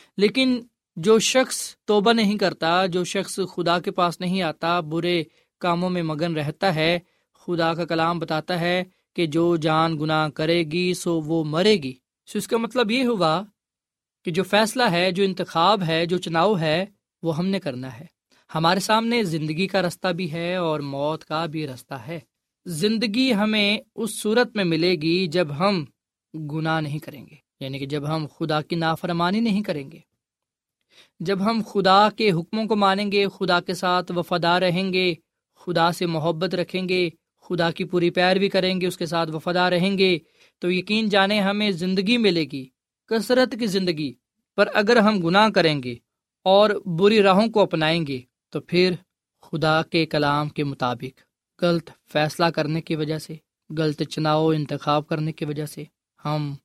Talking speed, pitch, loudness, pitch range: 175 wpm, 175 Hz, -22 LUFS, 160-195 Hz